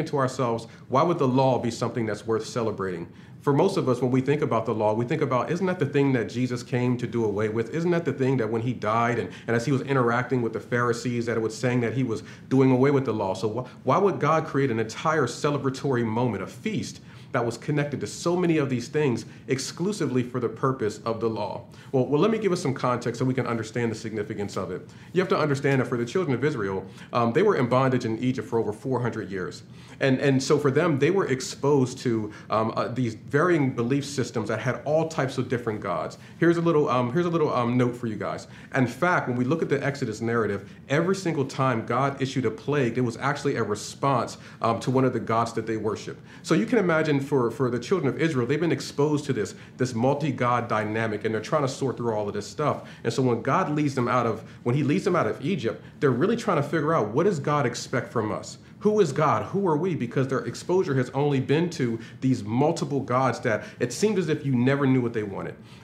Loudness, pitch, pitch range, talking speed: -25 LUFS, 130 Hz, 115-145 Hz, 250 wpm